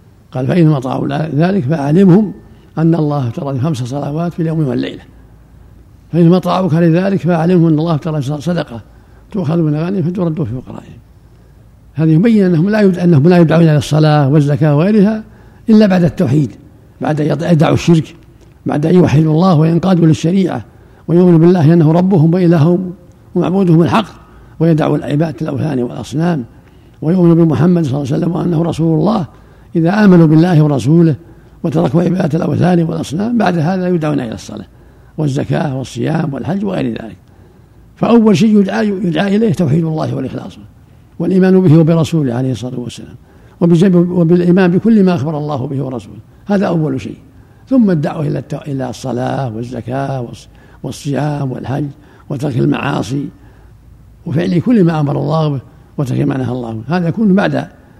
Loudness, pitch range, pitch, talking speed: -13 LUFS, 135-175 Hz, 160 Hz, 140 wpm